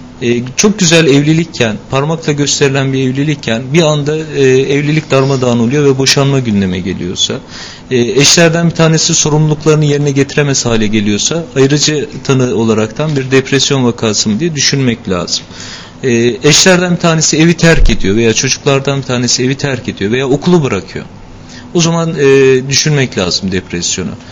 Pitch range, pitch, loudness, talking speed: 120-150 Hz, 135 Hz, -10 LUFS, 150 wpm